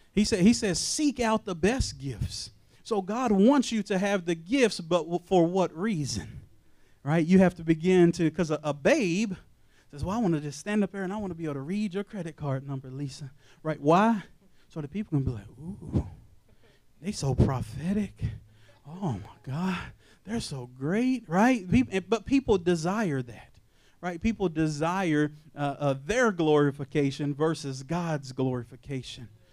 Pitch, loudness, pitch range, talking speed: 165 Hz, -28 LUFS, 135-200 Hz, 175 wpm